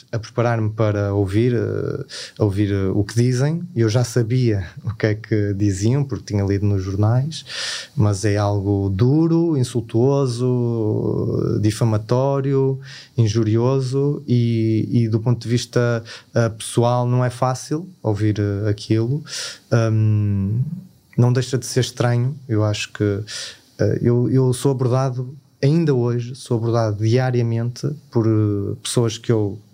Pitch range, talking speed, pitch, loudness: 110-130 Hz, 135 wpm, 120 Hz, -20 LUFS